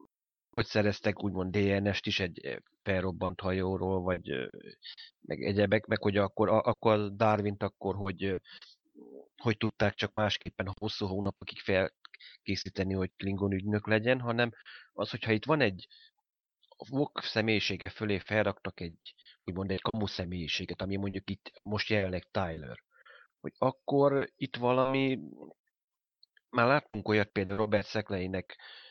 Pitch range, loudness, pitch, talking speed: 95-110 Hz, -32 LUFS, 100 Hz, 125 wpm